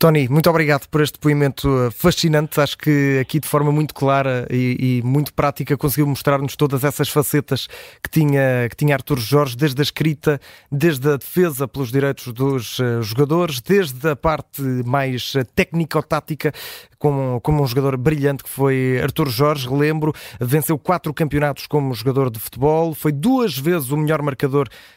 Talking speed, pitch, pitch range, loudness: 165 wpm, 145 Hz, 135-155 Hz, -19 LUFS